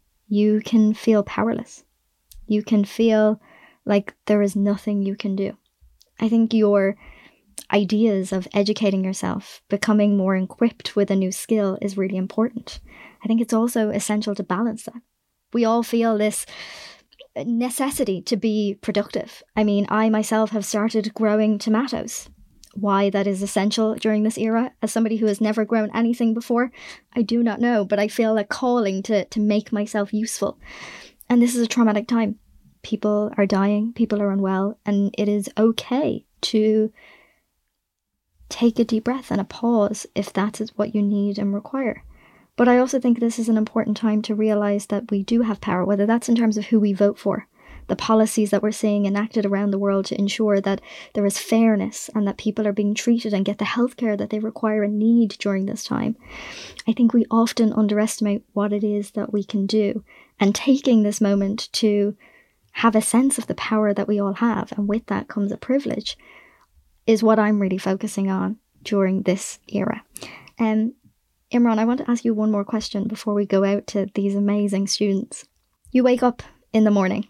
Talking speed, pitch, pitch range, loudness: 185 wpm, 215 Hz, 205-230 Hz, -21 LUFS